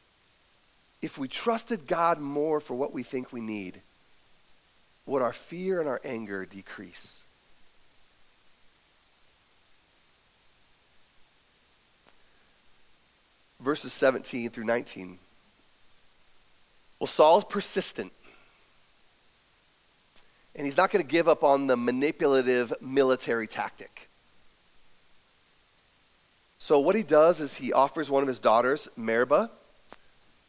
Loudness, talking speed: -27 LUFS, 95 wpm